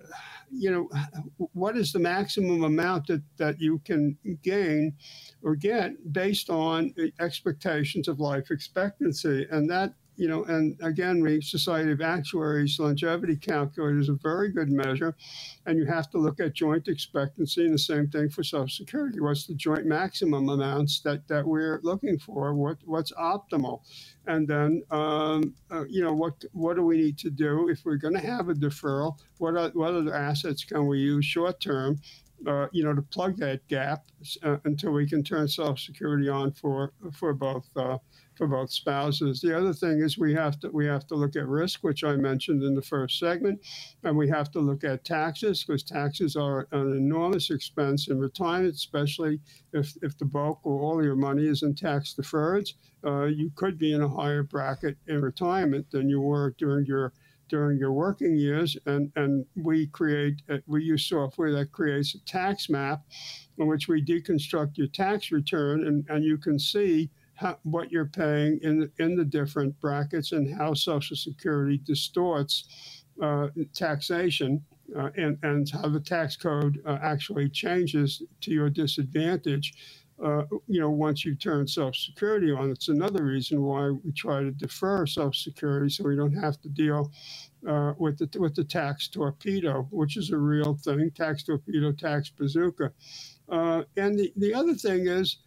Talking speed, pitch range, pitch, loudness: 180 wpm, 145-165 Hz, 150 Hz, -28 LUFS